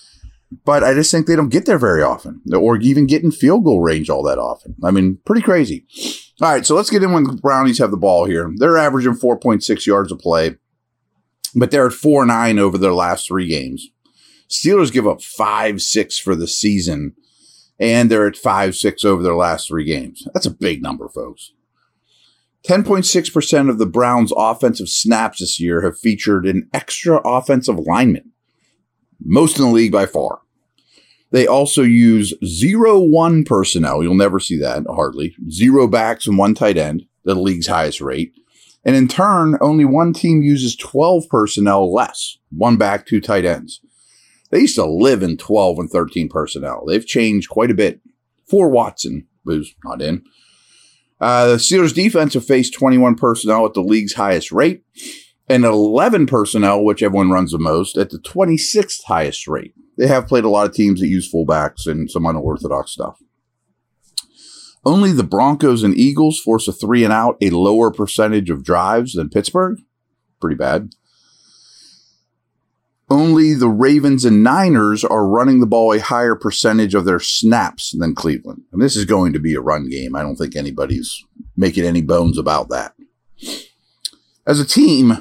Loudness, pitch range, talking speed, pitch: -15 LUFS, 95-145 Hz, 180 wpm, 115 Hz